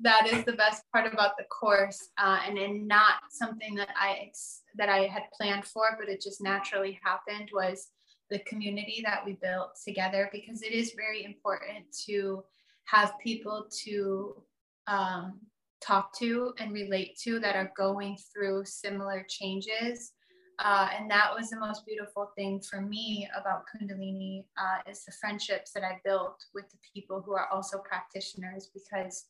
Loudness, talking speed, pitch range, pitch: -31 LUFS, 165 wpm, 195-215 Hz, 200 Hz